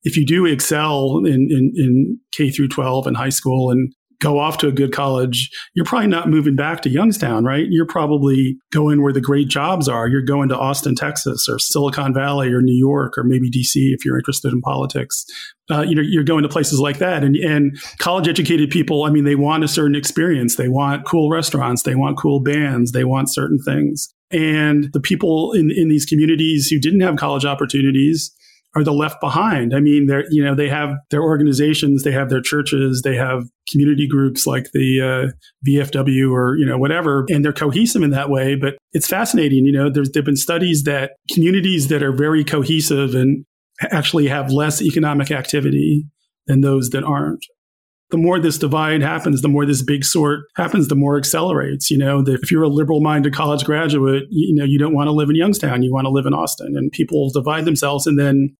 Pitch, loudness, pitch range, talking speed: 145 Hz, -16 LUFS, 135-155 Hz, 210 wpm